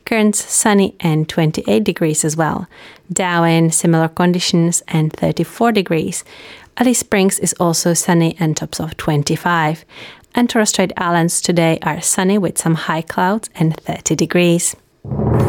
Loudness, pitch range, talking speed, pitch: -16 LUFS, 160-190 Hz, 135 wpm, 170 Hz